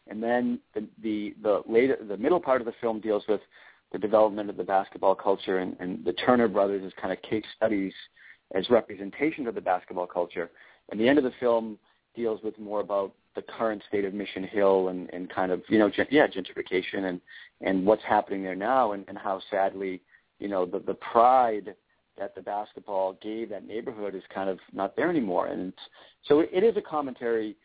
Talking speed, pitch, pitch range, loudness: 205 wpm, 105 Hz, 95-110 Hz, -27 LUFS